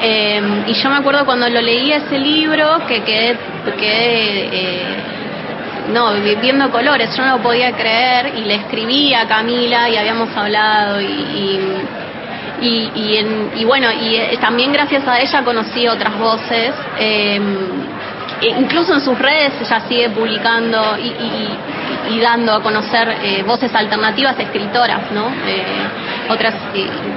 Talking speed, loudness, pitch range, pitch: 150 wpm, -14 LUFS, 220-255 Hz, 230 Hz